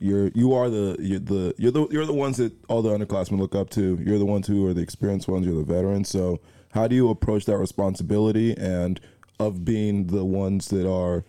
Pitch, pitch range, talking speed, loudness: 100 Hz, 95-110 Hz, 230 wpm, -24 LUFS